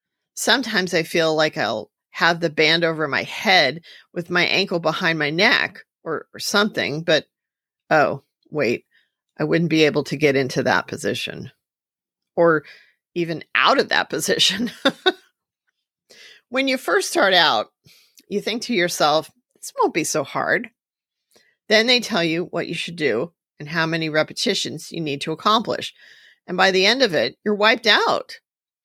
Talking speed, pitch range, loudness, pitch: 160 wpm, 160-220 Hz, -19 LUFS, 175 Hz